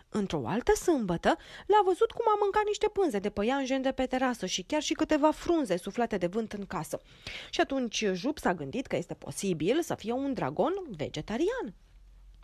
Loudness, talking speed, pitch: -30 LUFS, 185 wpm, 265 Hz